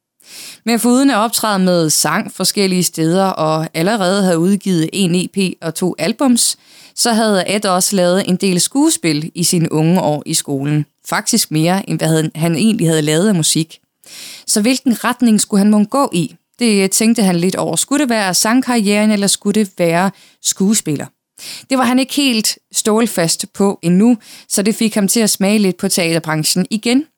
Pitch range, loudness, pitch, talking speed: 170-225 Hz, -14 LUFS, 195 Hz, 180 wpm